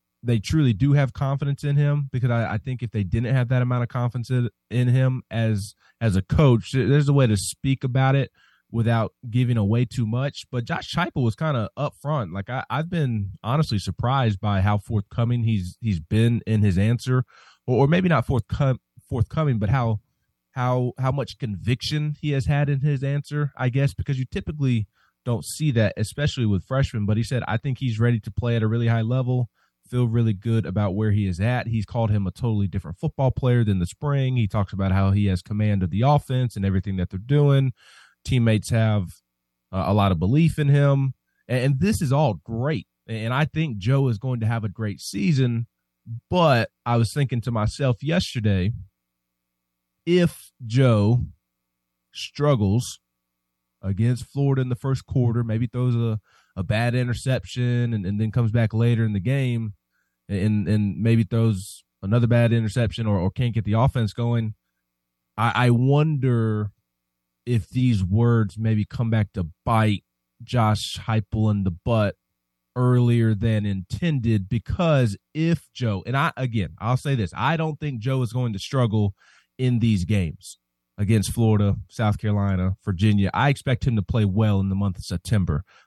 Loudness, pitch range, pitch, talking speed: -23 LUFS, 105-130 Hz, 115 Hz, 185 wpm